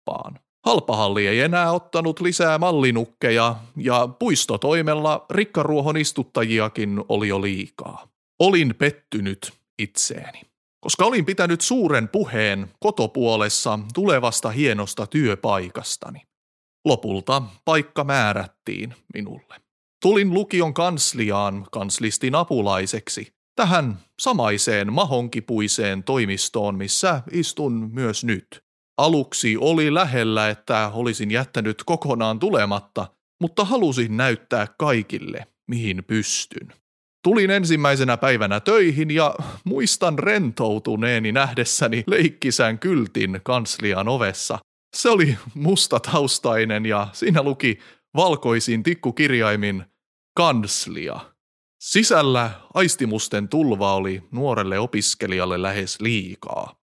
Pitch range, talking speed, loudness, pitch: 105-150 Hz, 90 wpm, -21 LUFS, 120 Hz